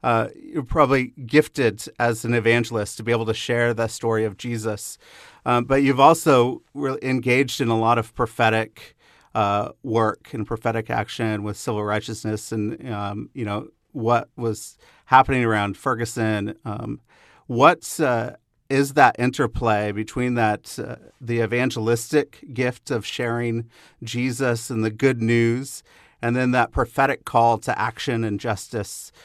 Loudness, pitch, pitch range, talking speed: -22 LUFS, 115 Hz, 110-130 Hz, 150 wpm